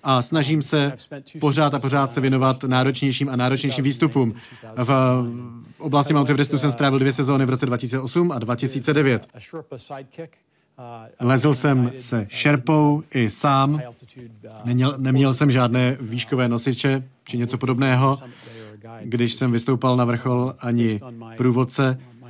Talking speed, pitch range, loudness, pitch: 125 wpm, 120-140 Hz, -20 LUFS, 130 Hz